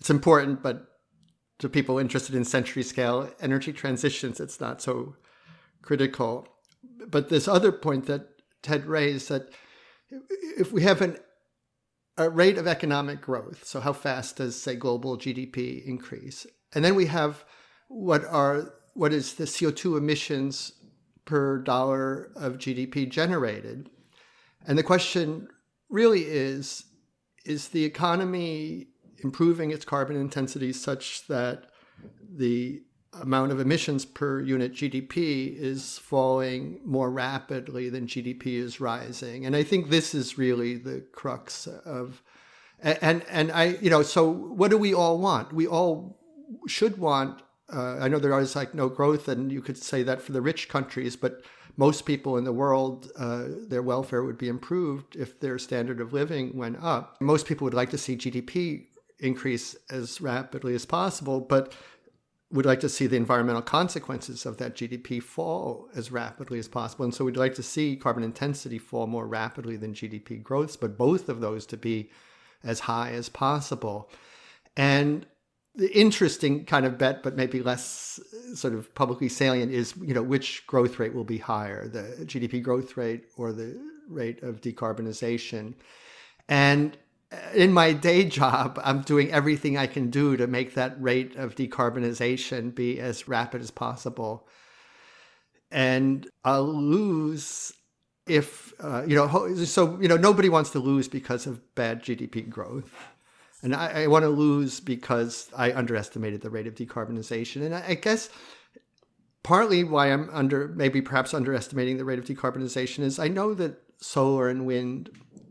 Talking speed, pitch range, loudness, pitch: 160 wpm, 125-155 Hz, -27 LUFS, 135 Hz